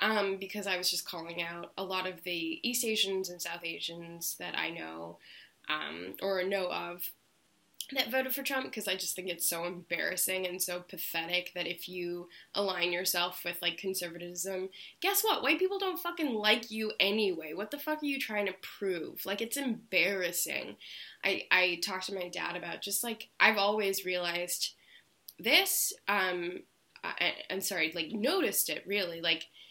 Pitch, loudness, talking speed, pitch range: 185 Hz, -32 LUFS, 175 wpm, 175-215 Hz